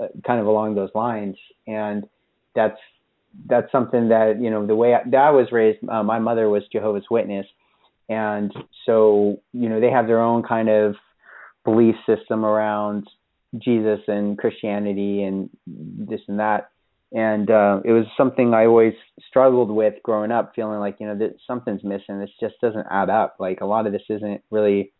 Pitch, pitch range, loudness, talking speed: 110 Hz, 105-115 Hz, -20 LUFS, 180 wpm